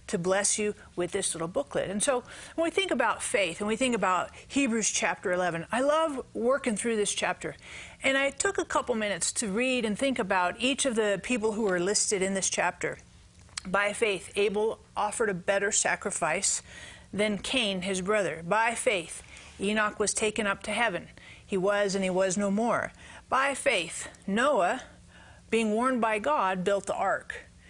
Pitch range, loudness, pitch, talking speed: 195-245 Hz, -28 LUFS, 210 Hz, 180 wpm